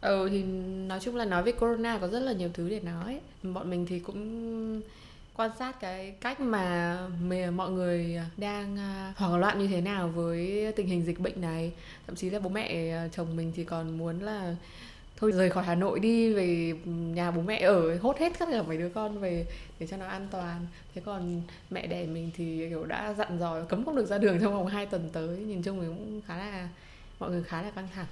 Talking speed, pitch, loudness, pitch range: 225 wpm, 185 Hz, -32 LUFS, 170-205 Hz